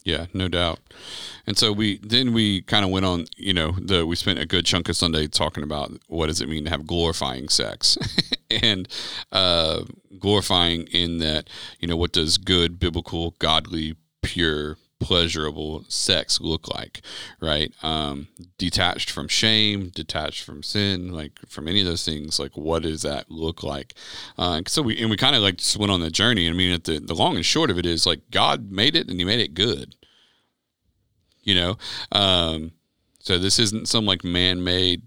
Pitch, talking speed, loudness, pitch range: 90 Hz, 190 wpm, -21 LUFS, 80-100 Hz